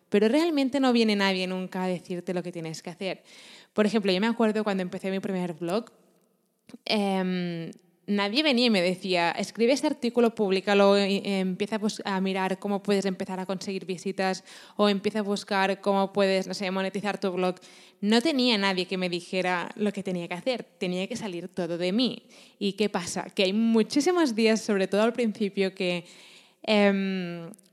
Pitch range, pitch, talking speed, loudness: 185-215 Hz, 195 Hz, 185 wpm, -26 LUFS